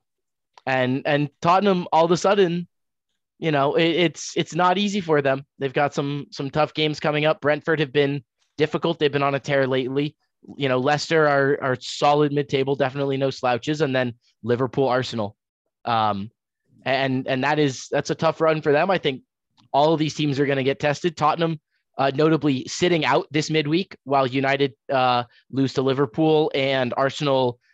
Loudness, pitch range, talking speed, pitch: -22 LUFS, 135-155 Hz, 185 wpm, 145 Hz